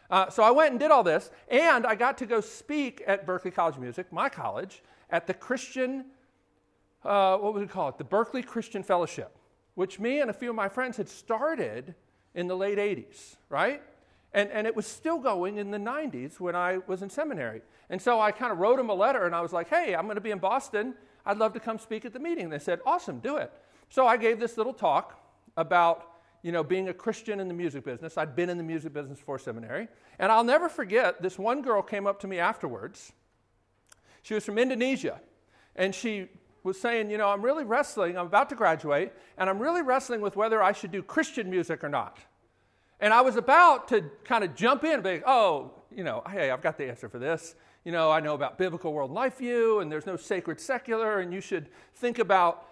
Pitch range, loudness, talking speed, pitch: 175-240 Hz, -28 LUFS, 235 wpm, 205 Hz